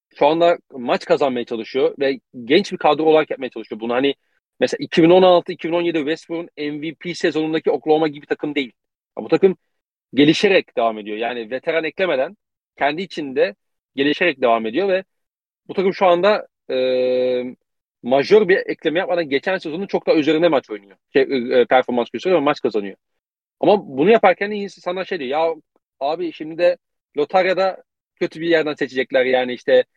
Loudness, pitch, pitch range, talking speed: -19 LUFS, 160 Hz, 130-185 Hz, 155 wpm